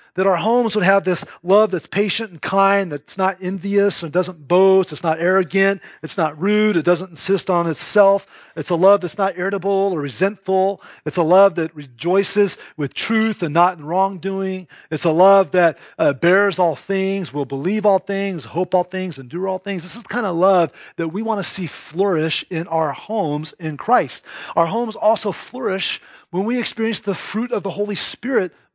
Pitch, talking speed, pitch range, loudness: 190 Hz, 200 wpm, 170-200 Hz, -19 LUFS